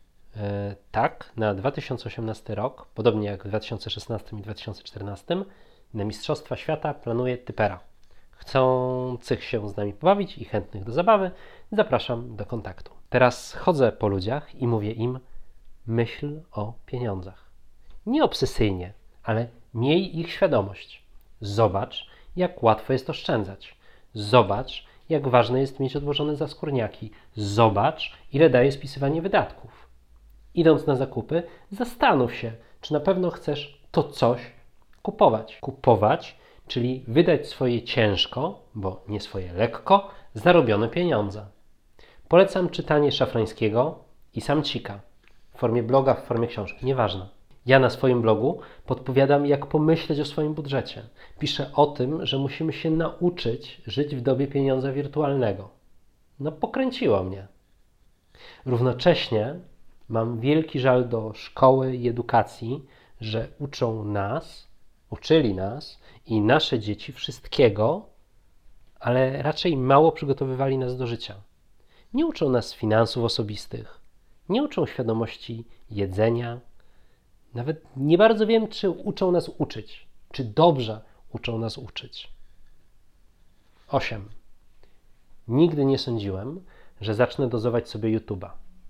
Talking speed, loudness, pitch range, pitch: 120 wpm, -24 LUFS, 110-145 Hz, 125 Hz